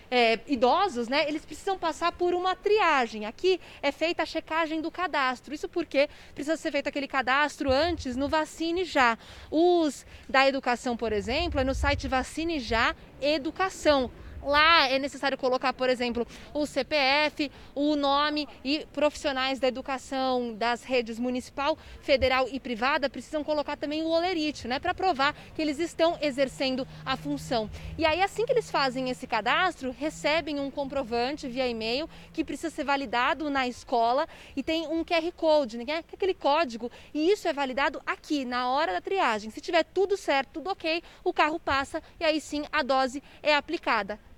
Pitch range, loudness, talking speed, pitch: 260-325 Hz, -27 LUFS, 170 wpm, 295 Hz